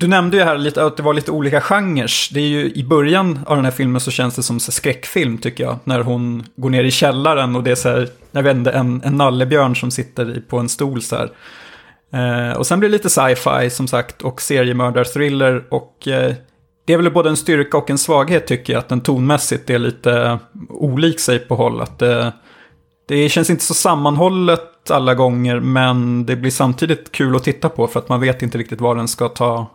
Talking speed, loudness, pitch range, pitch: 220 wpm, -16 LUFS, 125-150 Hz, 130 Hz